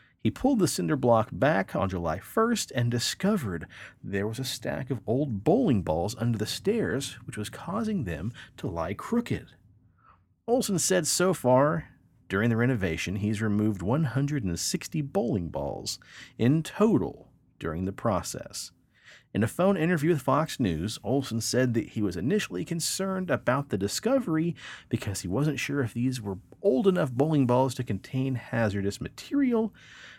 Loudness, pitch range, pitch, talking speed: -28 LUFS, 110-165 Hz, 130 Hz, 155 wpm